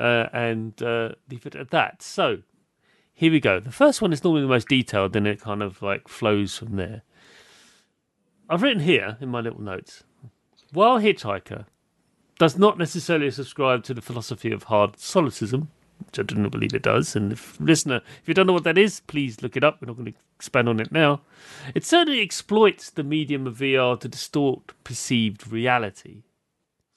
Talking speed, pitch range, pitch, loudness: 190 wpm, 110-155 Hz, 125 Hz, -22 LUFS